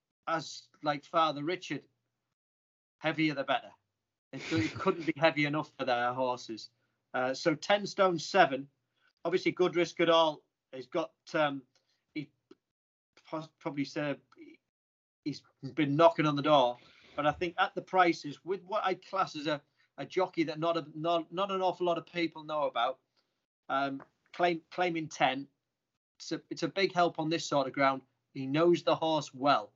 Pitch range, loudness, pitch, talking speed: 140-170 Hz, -31 LUFS, 155 Hz, 170 wpm